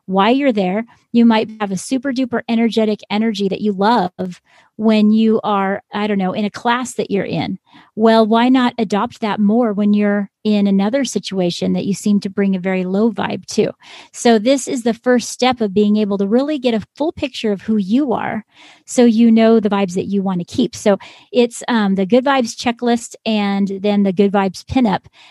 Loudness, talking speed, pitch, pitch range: -16 LUFS, 210 wpm, 215 Hz, 200-235 Hz